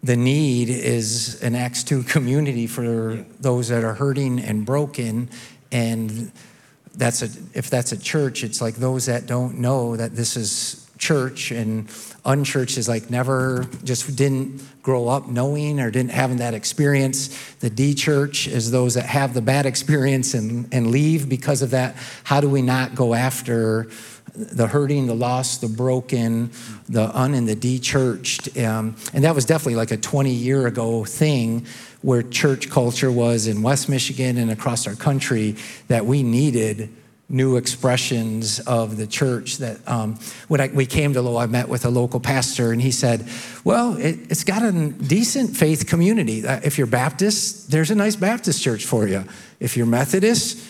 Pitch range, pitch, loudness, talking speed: 115-140 Hz, 125 Hz, -21 LUFS, 175 wpm